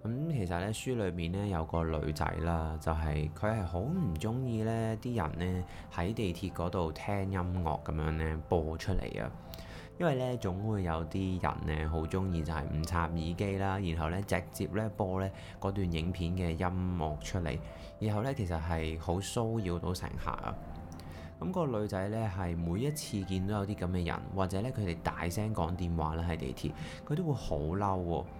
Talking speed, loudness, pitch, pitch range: 265 characters per minute, -35 LUFS, 90 Hz, 80-100 Hz